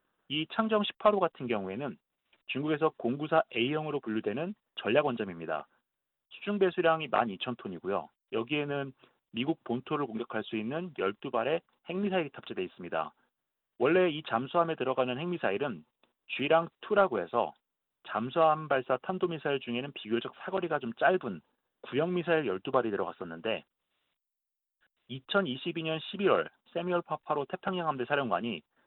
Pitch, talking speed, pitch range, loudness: 155 Hz, 300 characters per minute, 125-175 Hz, -32 LUFS